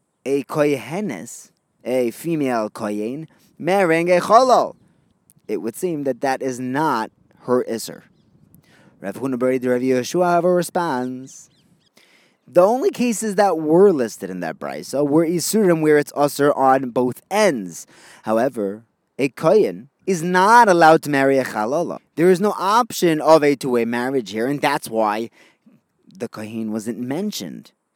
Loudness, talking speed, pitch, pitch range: -19 LUFS, 140 wpm, 140 Hz, 125-175 Hz